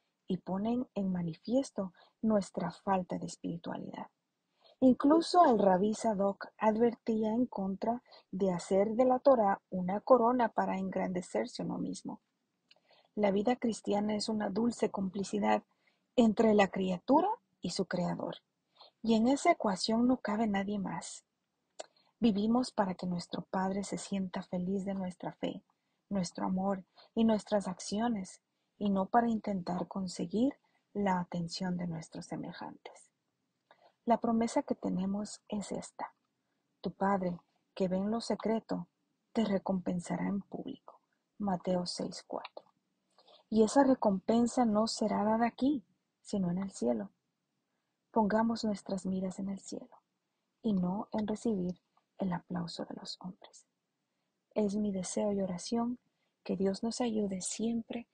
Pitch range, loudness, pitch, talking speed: 190-230 Hz, -33 LUFS, 210 Hz, 130 wpm